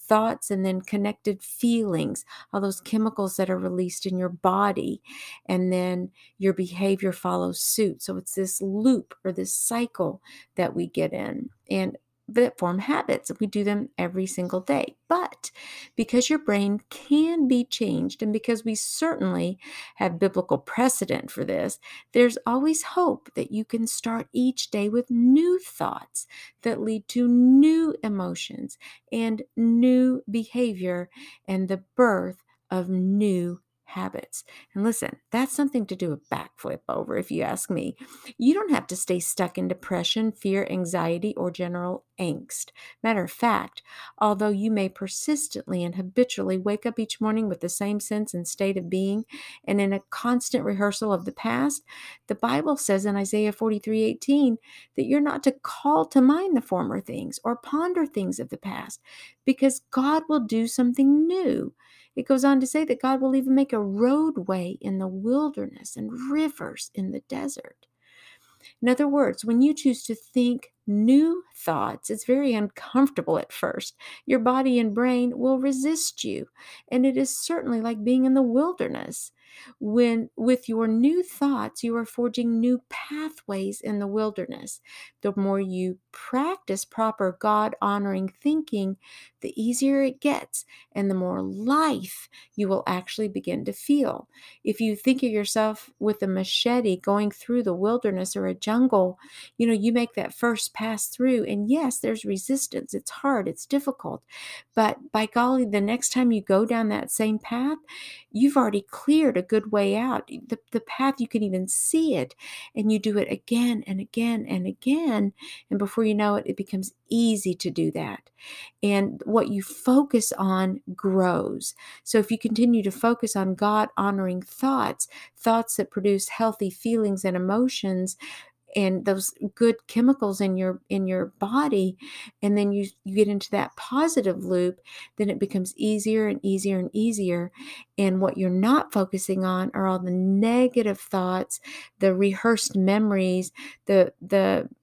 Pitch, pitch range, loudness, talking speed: 220 Hz, 195-255 Hz, -25 LUFS, 165 wpm